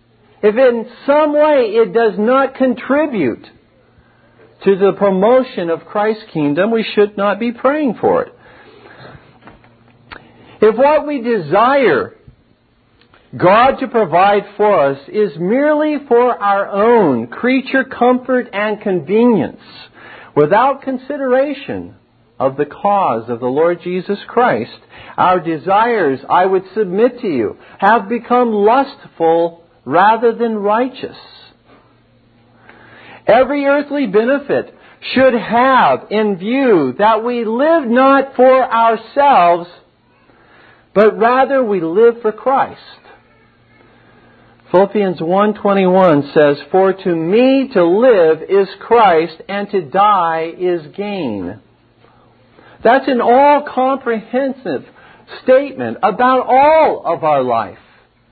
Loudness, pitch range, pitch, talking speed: -13 LUFS, 175-260 Hz, 215 Hz, 110 wpm